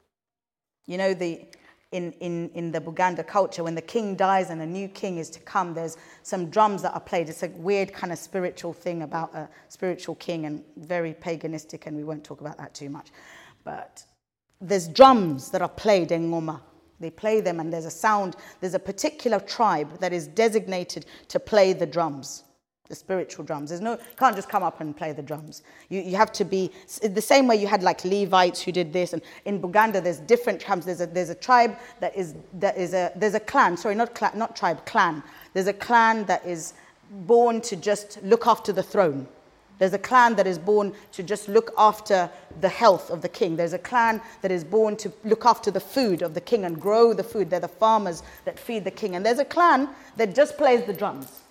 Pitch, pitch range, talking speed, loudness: 190 Hz, 170-215 Hz, 220 wpm, -24 LUFS